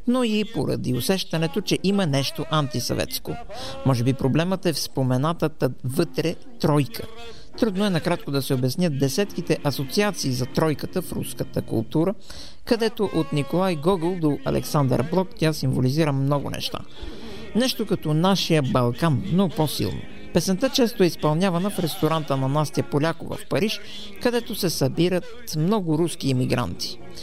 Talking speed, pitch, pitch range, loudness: 140 wpm, 160 Hz, 140-190 Hz, -24 LUFS